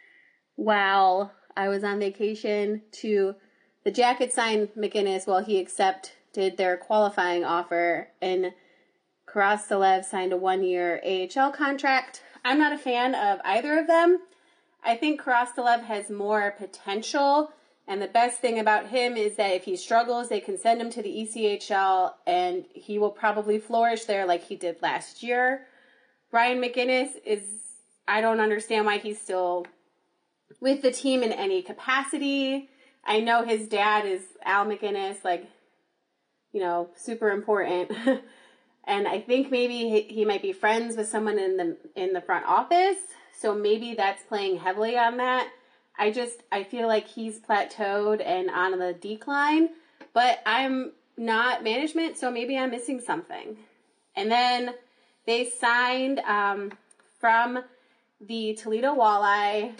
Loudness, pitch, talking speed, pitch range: -26 LUFS, 220 Hz, 150 wpm, 200-255 Hz